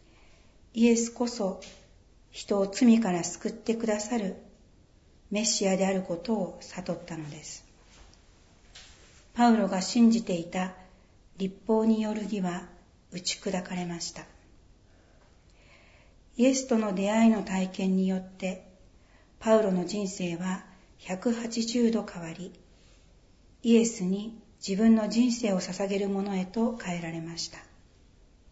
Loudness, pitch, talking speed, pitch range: -28 LUFS, 195 Hz, 225 characters per minute, 175-220 Hz